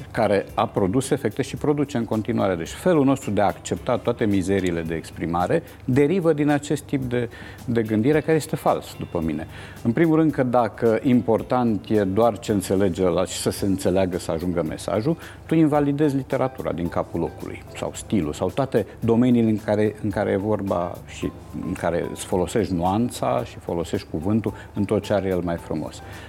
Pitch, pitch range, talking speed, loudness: 110 Hz, 95-125 Hz, 185 wpm, -23 LUFS